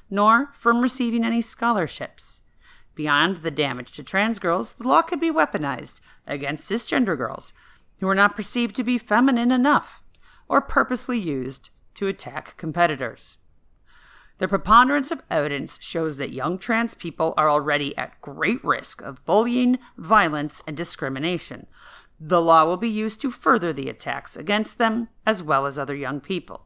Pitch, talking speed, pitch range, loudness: 195 Hz, 155 wpm, 150-235 Hz, -22 LUFS